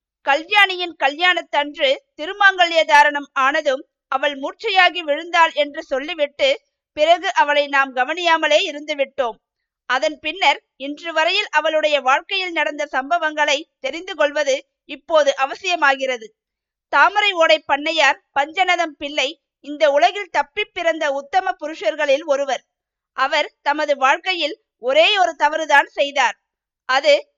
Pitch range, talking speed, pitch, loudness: 280-330 Hz, 100 wpm, 300 Hz, -18 LUFS